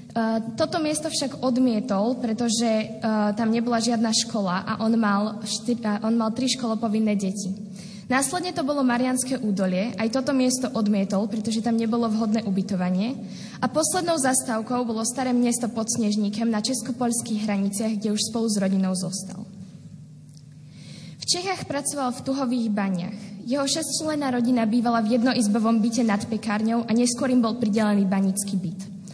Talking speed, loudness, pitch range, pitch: 150 wpm, -24 LUFS, 205-245 Hz, 225 Hz